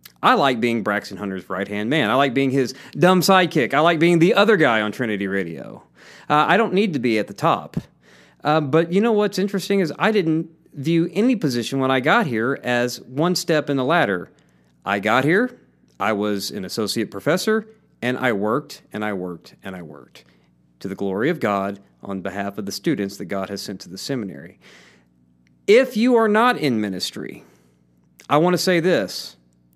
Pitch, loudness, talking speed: 120 Hz, -20 LUFS, 200 wpm